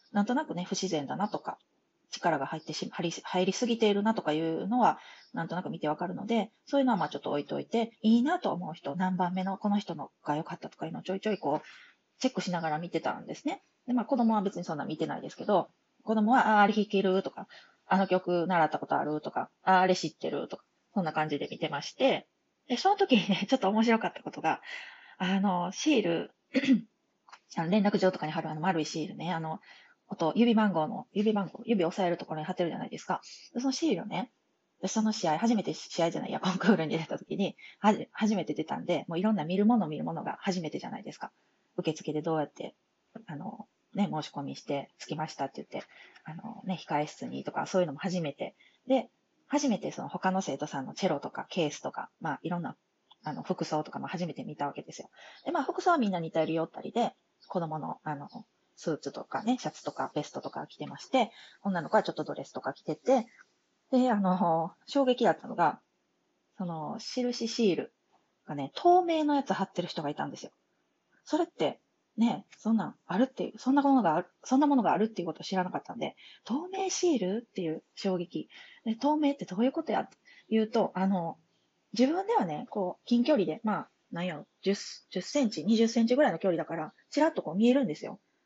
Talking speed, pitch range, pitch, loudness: 415 characters per minute, 170-245 Hz, 195 Hz, -31 LUFS